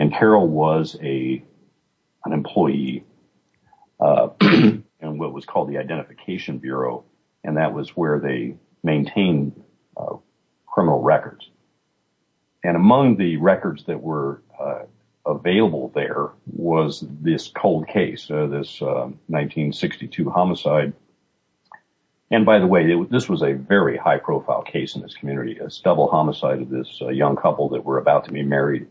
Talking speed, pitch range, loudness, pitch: 140 wpm, 70-80 Hz, -20 LUFS, 70 Hz